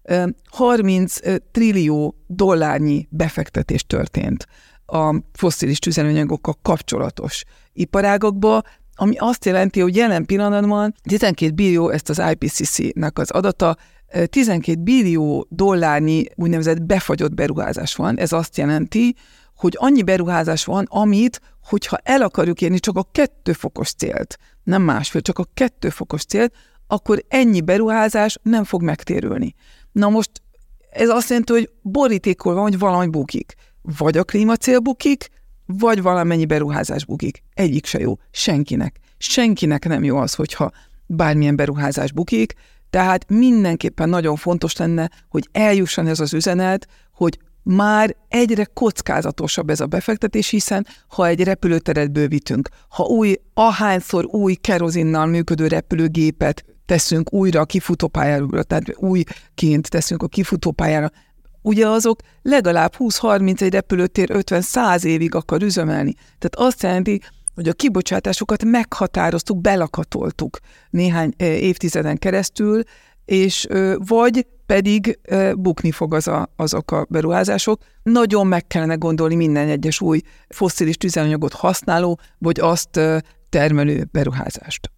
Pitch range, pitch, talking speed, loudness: 160-210 Hz, 180 Hz, 120 wpm, -18 LUFS